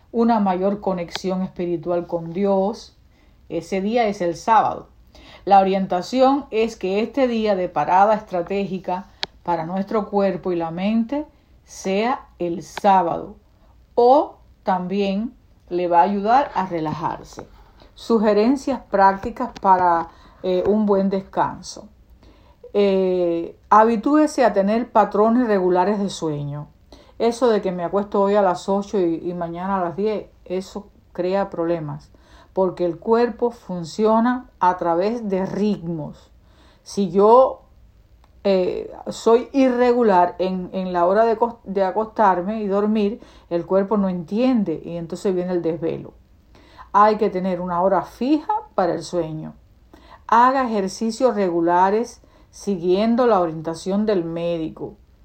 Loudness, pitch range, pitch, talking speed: -20 LUFS, 175-220 Hz, 195 Hz, 130 wpm